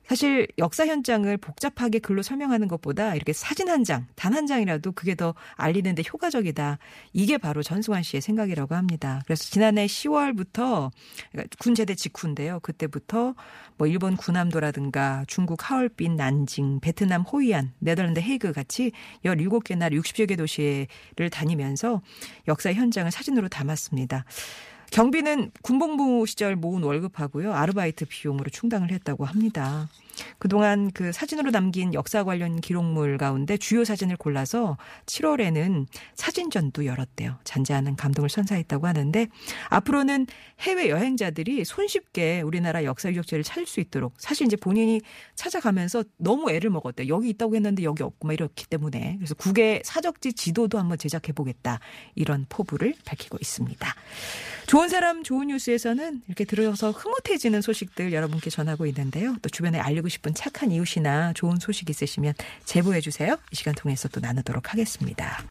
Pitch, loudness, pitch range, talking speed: 180 Hz, -26 LUFS, 155-225 Hz, 375 characters per minute